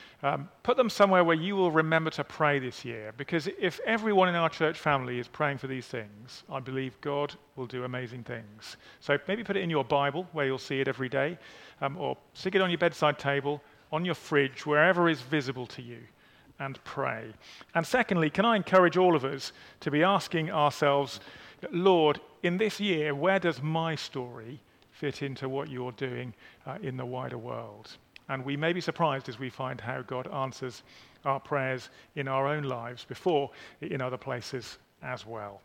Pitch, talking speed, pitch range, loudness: 140 Hz, 195 wpm, 130-165 Hz, -29 LUFS